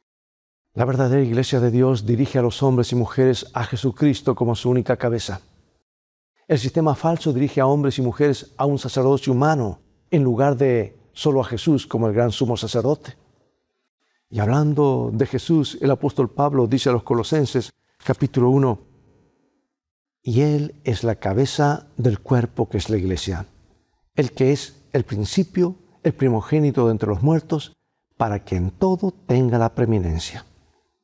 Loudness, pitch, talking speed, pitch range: -21 LUFS, 130 Hz, 160 wpm, 115-140 Hz